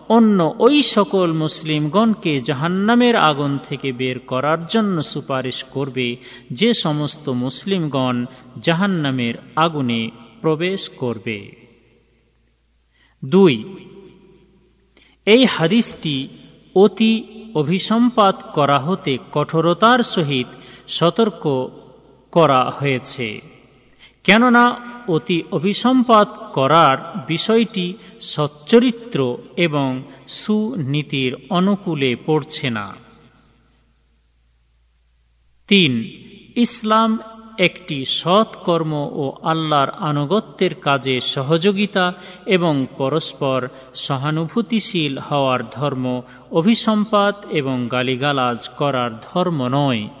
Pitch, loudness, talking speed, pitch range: 155 Hz, -18 LUFS, 75 wpm, 130-195 Hz